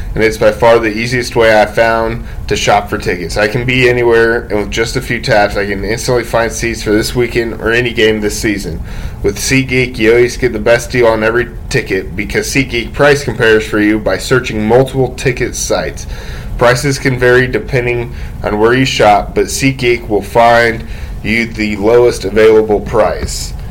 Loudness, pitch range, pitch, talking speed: -11 LUFS, 105-125 Hz, 115 Hz, 190 wpm